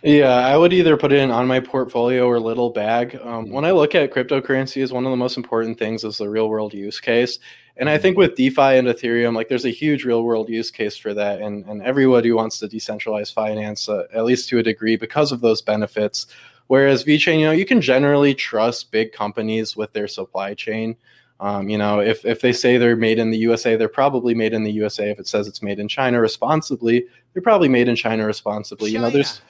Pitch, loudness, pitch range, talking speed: 115 Hz, -19 LUFS, 110-130 Hz, 230 wpm